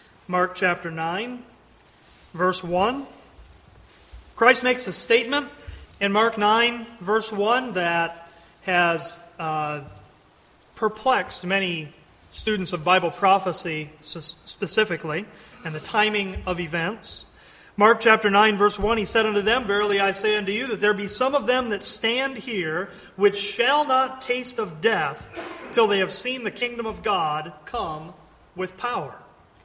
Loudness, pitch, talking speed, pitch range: -23 LUFS, 205 Hz, 140 wpm, 175-230 Hz